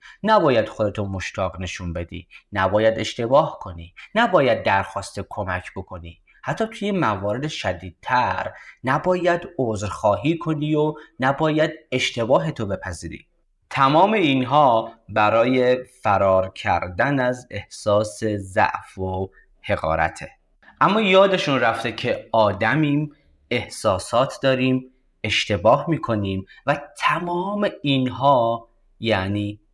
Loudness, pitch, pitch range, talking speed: -21 LUFS, 115 Hz, 100-145 Hz, 95 wpm